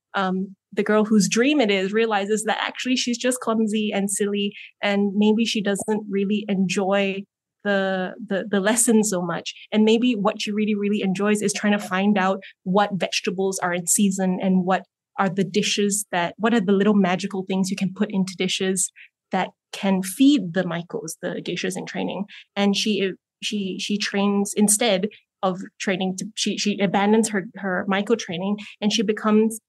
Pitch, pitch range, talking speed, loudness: 200 Hz, 190-215 Hz, 180 wpm, -22 LUFS